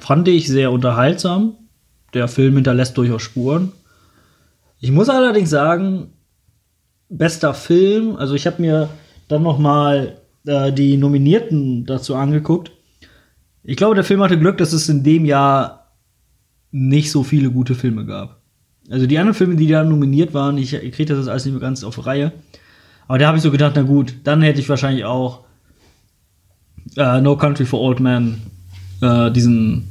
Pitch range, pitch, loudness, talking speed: 125-155 Hz, 140 Hz, -16 LUFS, 165 wpm